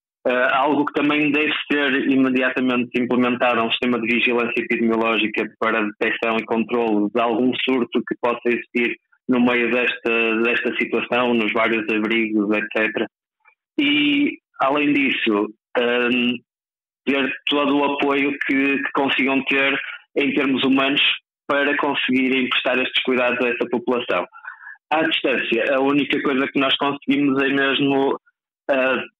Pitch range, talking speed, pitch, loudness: 120-140 Hz, 135 wpm, 125 Hz, -19 LUFS